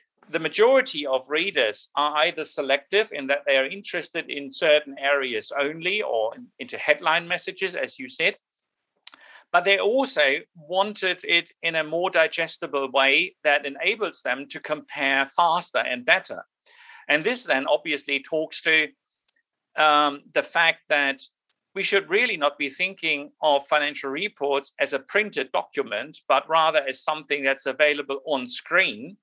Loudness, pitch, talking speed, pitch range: -23 LUFS, 155 Hz, 150 wpm, 140-185 Hz